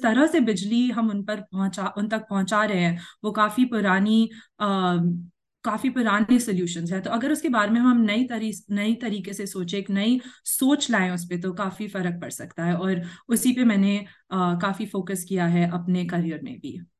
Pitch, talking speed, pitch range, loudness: 205 Hz, 200 wpm, 185-225 Hz, -24 LUFS